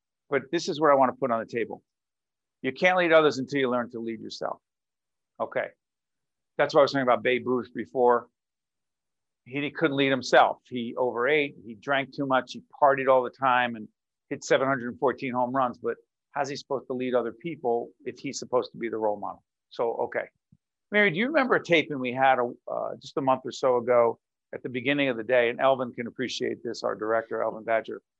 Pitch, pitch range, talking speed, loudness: 130 Hz, 120-140 Hz, 215 wpm, -26 LUFS